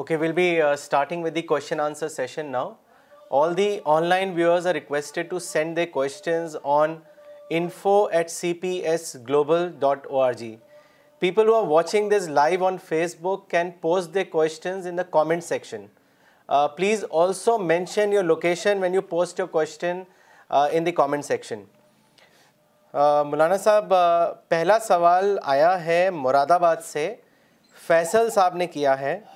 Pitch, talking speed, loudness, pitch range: 170 Hz, 155 wpm, -22 LUFS, 155-190 Hz